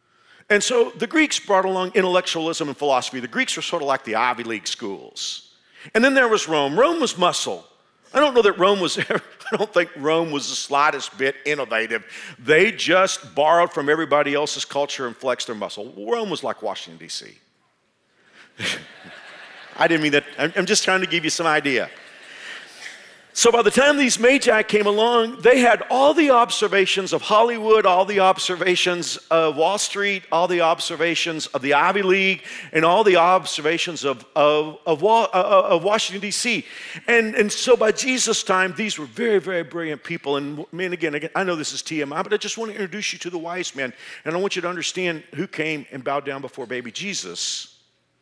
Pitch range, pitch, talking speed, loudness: 150-210 Hz, 175 Hz, 190 wpm, -20 LUFS